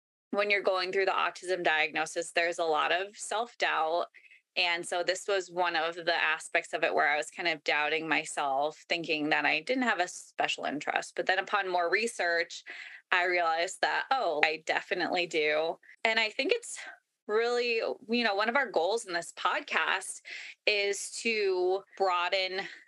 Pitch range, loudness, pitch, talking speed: 170-200 Hz, -29 LUFS, 180 Hz, 175 wpm